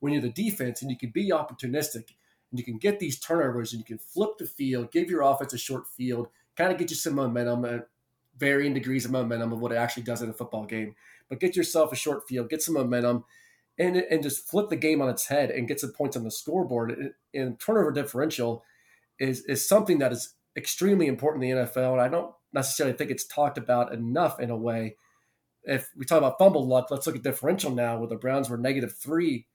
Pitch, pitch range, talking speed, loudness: 130 Hz, 120-155 Hz, 230 wpm, -27 LUFS